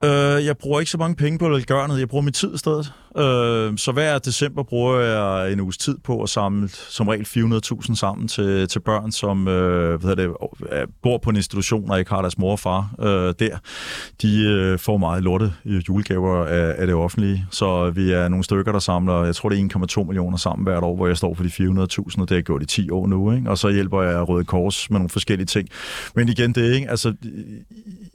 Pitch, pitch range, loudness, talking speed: 100 Hz, 95-120 Hz, -21 LUFS, 215 wpm